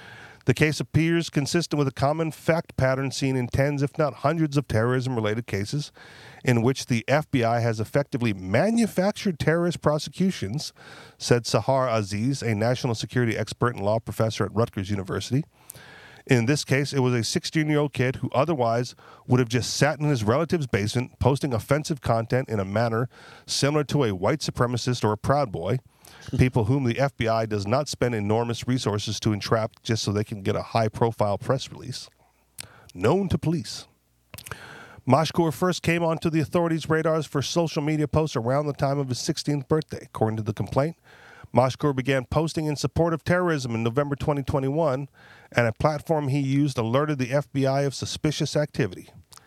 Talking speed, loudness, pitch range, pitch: 175 wpm, -25 LUFS, 115-150 Hz, 135 Hz